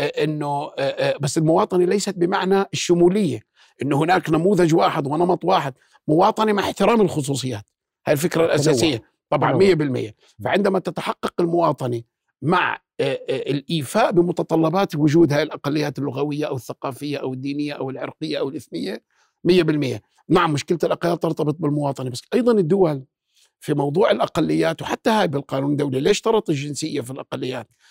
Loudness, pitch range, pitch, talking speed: -21 LUFS, 140-185 Hz, 155 Hz, 125 wpm